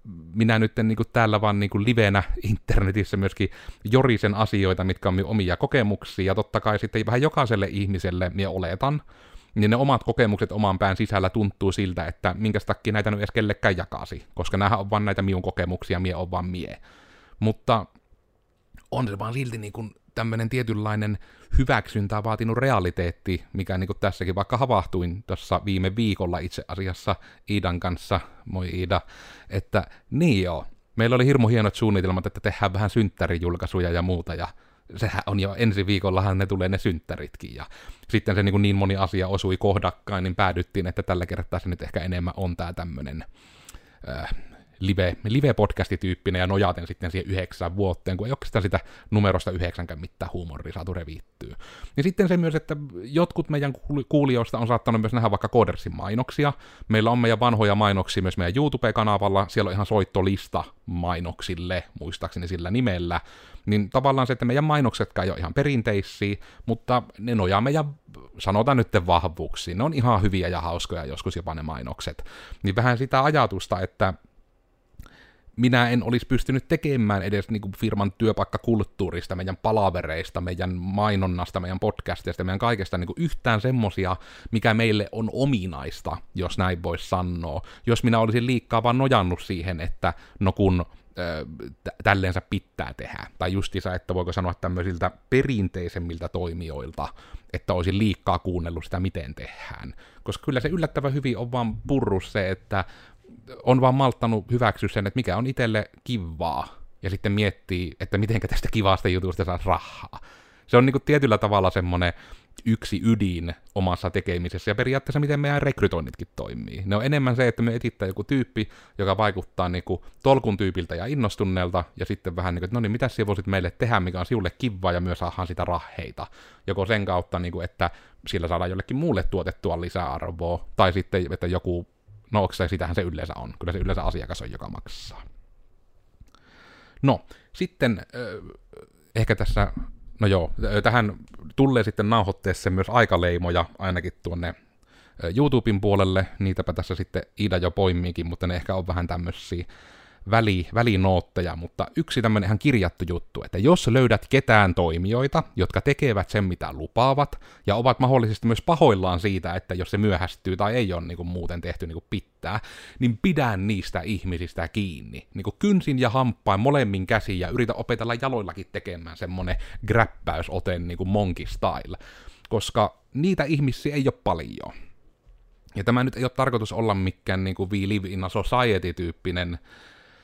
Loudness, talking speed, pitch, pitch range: -25 LUFS, 165 wpm, 100 Hz, 90-115 Hz